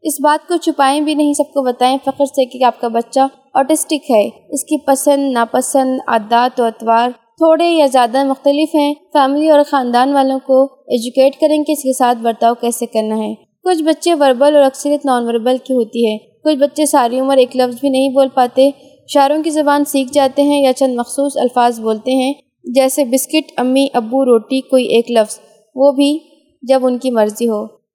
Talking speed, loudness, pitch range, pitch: 195 wpm, -14 LUFS, 245-285 Hz, 270 Hz